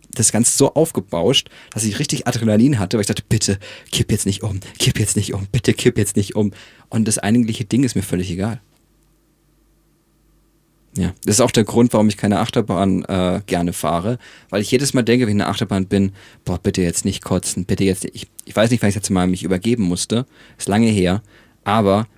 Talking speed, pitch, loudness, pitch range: 225 wpm, 110 Hz, -18 LUFS, 100-125 Hz